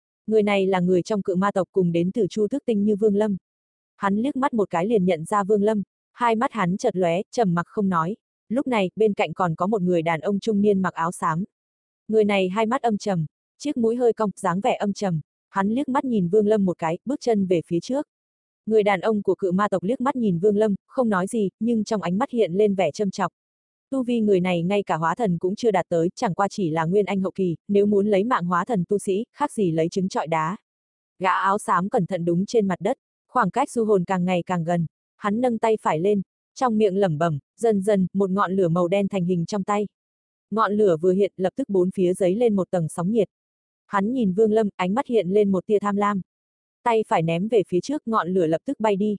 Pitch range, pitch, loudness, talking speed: 185-220 Hz, 200 Hz, -23 LUFS, 255 wpm